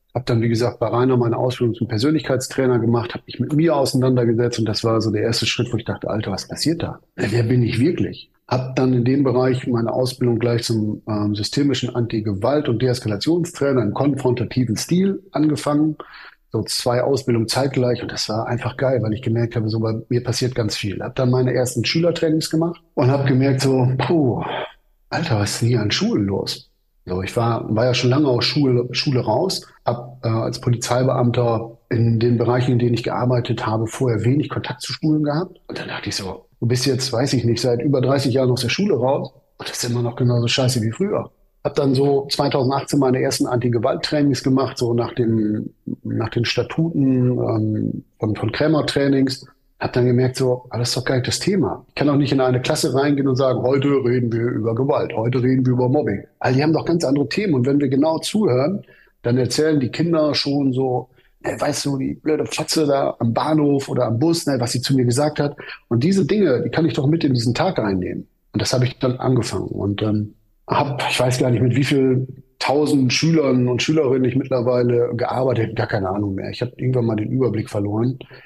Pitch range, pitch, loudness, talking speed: 120-140 Hz, 125 Hz, -20 LUFS, 215 wpm